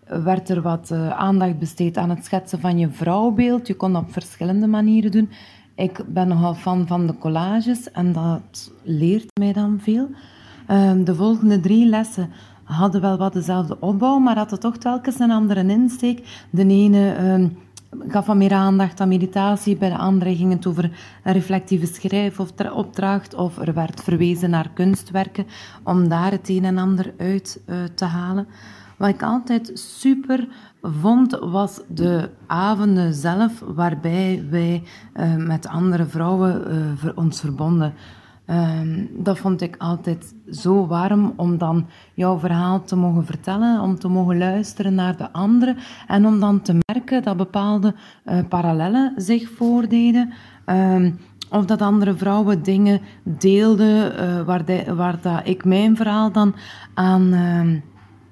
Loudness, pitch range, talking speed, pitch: -19 LUFS, 175-205 Hz, 150 wpm, 190 Hz